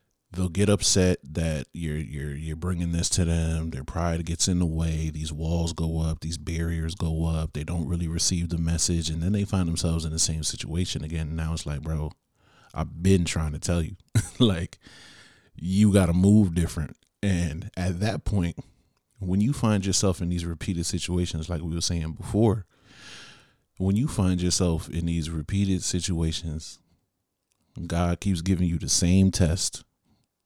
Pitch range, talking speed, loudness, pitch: 80-95 Hz, 175 wpm, -26 LUFS, 85 Hz